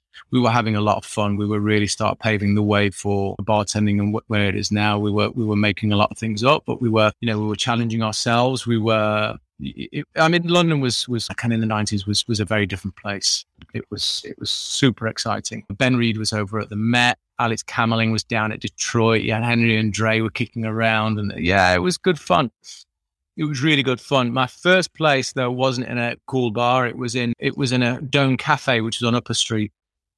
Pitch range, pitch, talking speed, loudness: 105-125 Hz, 115 Hz, 240 wpm, -20 LUFS